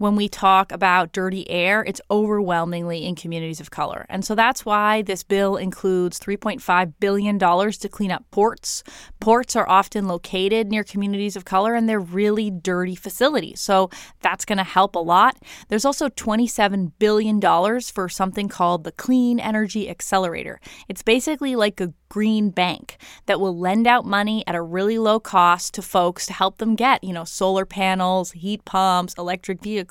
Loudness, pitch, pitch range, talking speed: -21 LUFS, 200 Hz, 185-215 Hz, 175 wpm